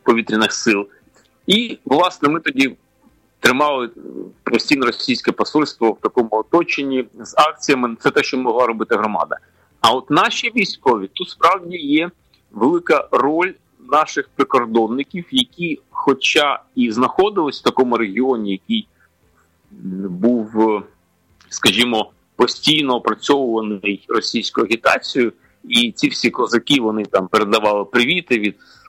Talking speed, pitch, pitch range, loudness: 115 wpm, 125 Hz, 110-175 Hz, -17 LUFS